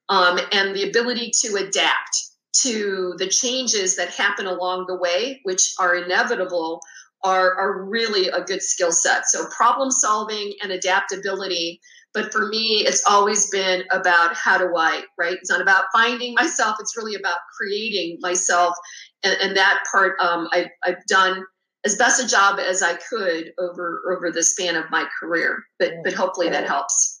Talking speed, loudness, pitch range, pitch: 170 wpm, -20 LUFS, 180-210 Hz, 190 Hz